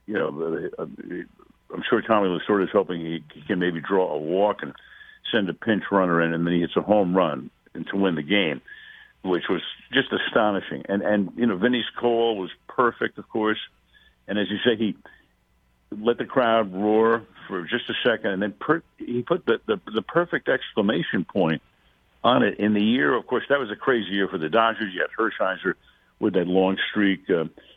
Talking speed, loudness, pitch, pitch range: 200 wpm, -24 LUFS, 105 Hz, 95-115 Hz